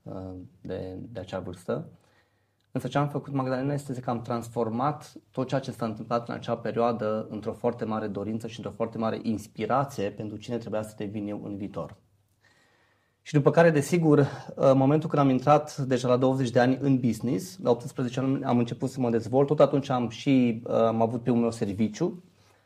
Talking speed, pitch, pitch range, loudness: 190 wpm, 120 Hz, 110-135 Hz, -27 LUFS